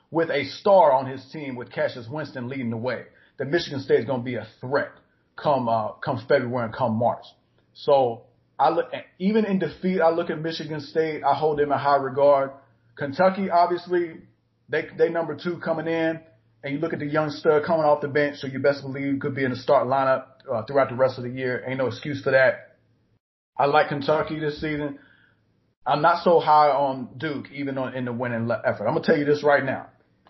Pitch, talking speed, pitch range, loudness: 145 Hz, 220 wpm, 130-160 Hz, -23 LUFS